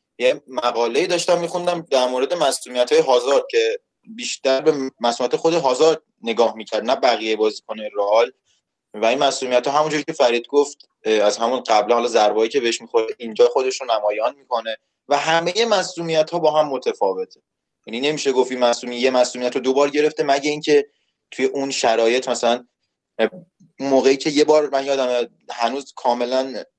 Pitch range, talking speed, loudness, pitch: 120-165 Hz, 160 wpm, -19 LUFS, 135 Hz